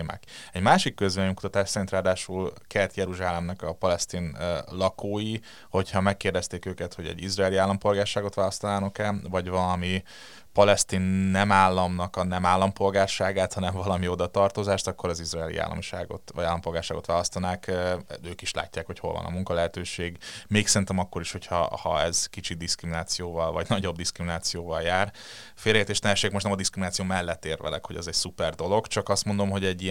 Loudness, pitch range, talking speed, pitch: -27 LUFS, 90-100 Hz, 160 wpm, 95 Hz